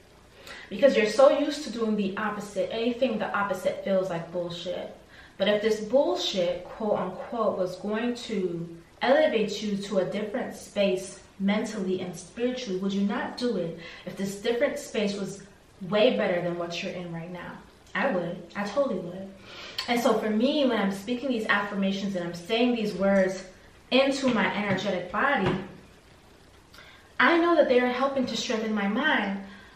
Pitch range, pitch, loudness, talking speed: 190-240 Hz, 205 Hz, -27 LUFS, 165 wpm